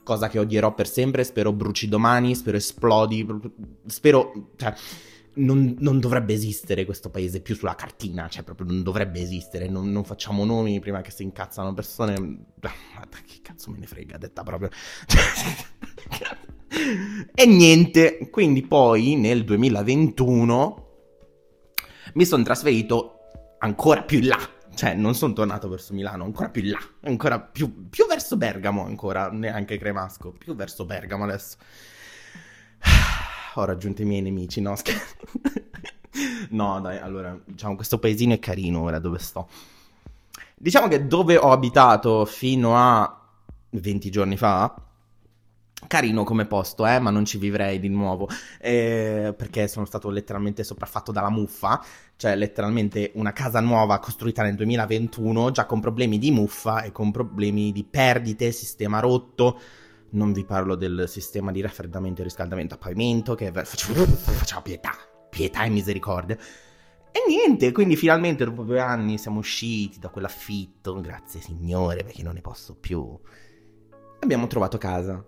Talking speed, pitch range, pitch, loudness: 145 wpm, 100-115 Hz, 105 Hz, -22 LUFS